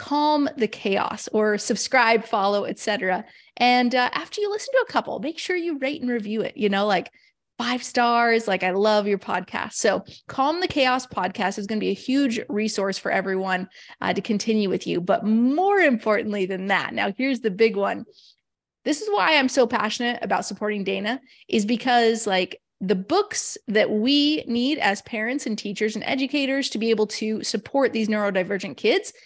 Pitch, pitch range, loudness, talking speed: 225 Hz, 205-265 Hz, -23 LUFS, 190 wpm